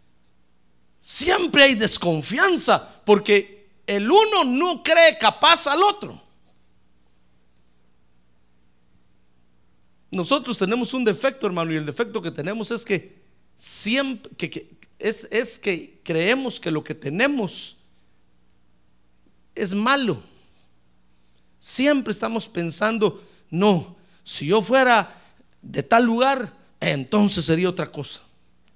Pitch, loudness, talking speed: 190 Hz, -19 LUFS, 105 wpm